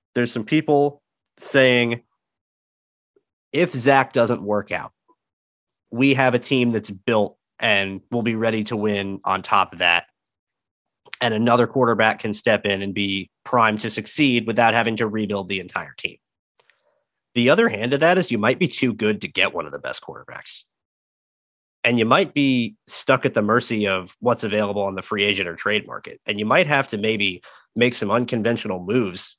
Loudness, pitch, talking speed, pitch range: -20 LUFS, 115 Hz, 180 wpm, 105-125 Hz